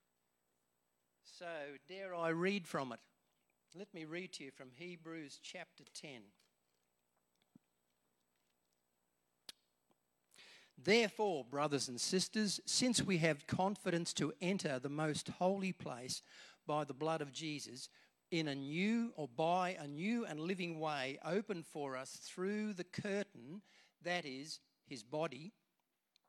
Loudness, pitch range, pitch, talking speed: -40 LUFS, 115-180 Hz, 155 Hz, 125 wpm